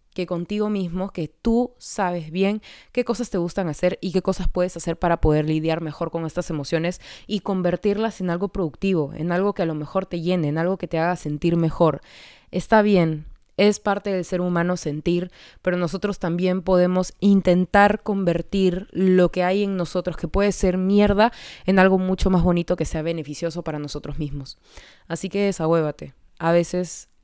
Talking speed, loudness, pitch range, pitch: 185 wpm, -22 LUFS, 165-195 Hz, 180 Hz